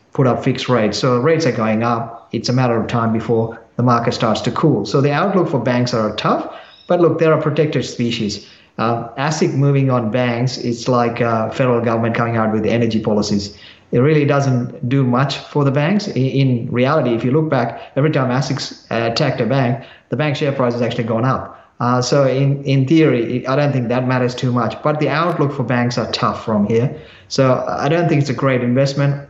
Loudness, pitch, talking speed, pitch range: -17 LUFS, 125 Hz, 225 wpm, 115-140 Hz